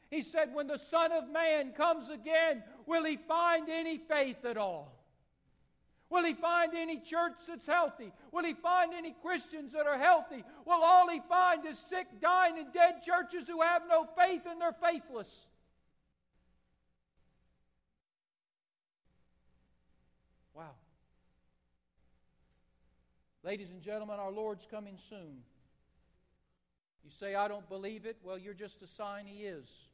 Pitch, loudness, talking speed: 225 Hz, -32 LUFS, 140 wpm